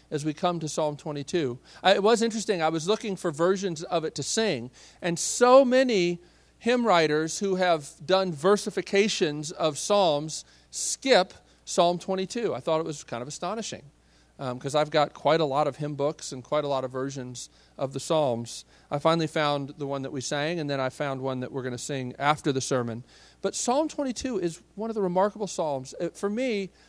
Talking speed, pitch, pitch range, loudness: 200 wpm, 160 Hz, 140-190 Hz, -27 LUFS